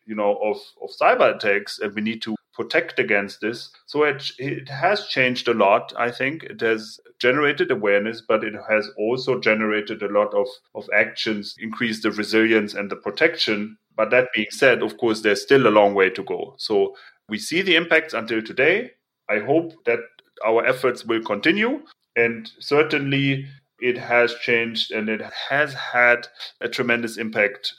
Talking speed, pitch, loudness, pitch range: 175 wpm, 115 Hz, -21 LUFS, 110-140 Hz